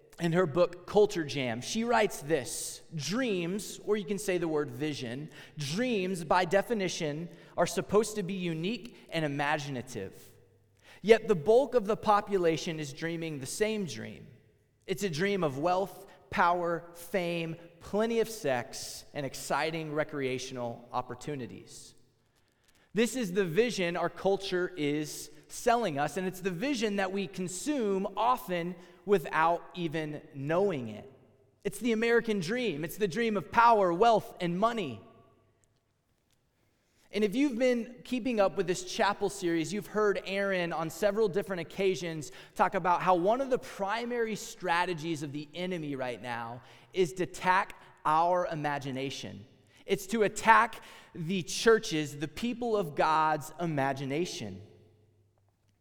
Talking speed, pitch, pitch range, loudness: 140 wpm, 175 Hz, 140-205 Hz, -31 LUFS